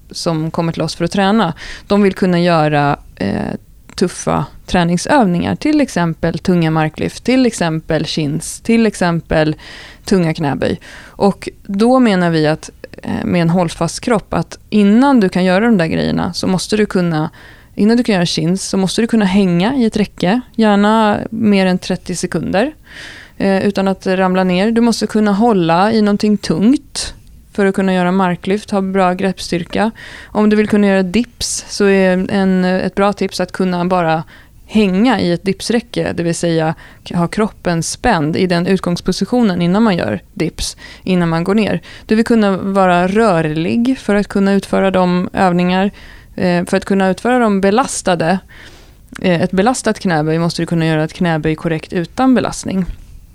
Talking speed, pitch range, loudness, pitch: 170 wpm, 170-210 Hz, -15 LUFS, 190 Hz